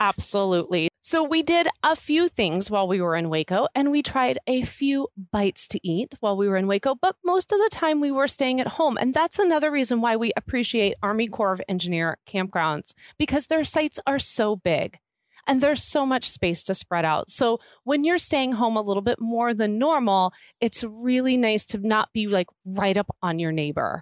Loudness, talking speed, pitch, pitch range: -23 LUFS, 210 wpm, 230 Hz, 195-280 Hz